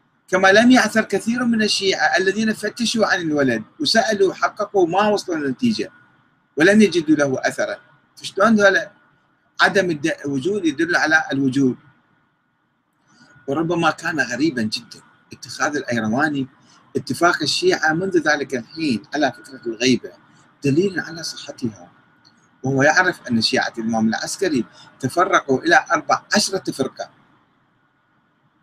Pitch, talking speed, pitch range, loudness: 175 Hz, 115 wpm, 135-210 Hz, -19 LUFS